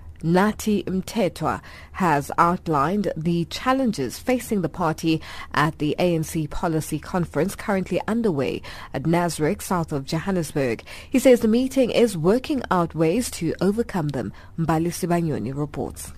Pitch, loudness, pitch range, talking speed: 170 Hz, -23 LUFS, 155-200 Hz, 130 wpm